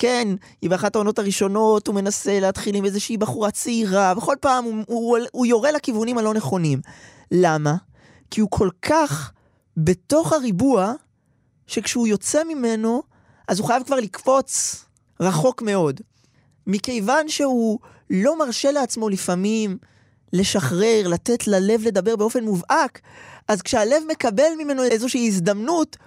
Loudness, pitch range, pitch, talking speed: -21 LUFS, 190-250 Hz, 220 Hz, 130 wpm